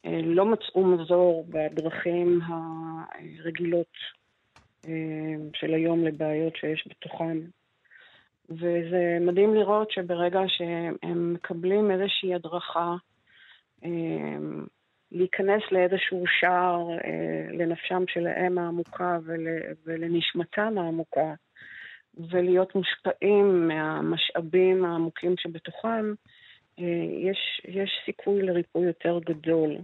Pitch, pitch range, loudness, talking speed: 175 Hz, 165-185 Hz, -27 LUFS, 75 wpm